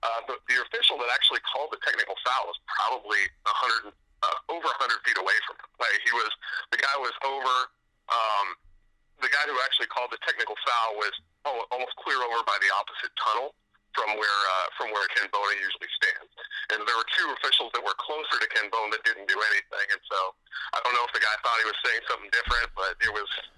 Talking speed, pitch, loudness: 215 wpm, 135 Hz, -26 LUFS